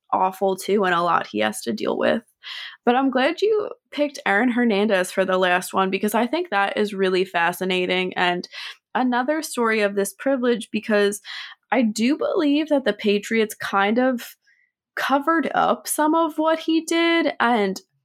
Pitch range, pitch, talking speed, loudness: 190-290 Hz, 220 Hz, 170 wpm, -21 LUFS